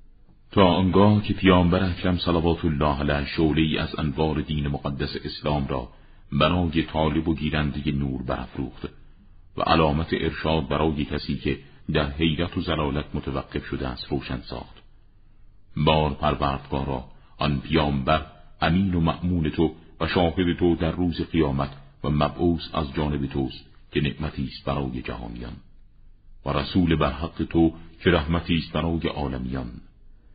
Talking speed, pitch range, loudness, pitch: 140 wpm, 70-85 Hz, -24 LUFS, 75 Hz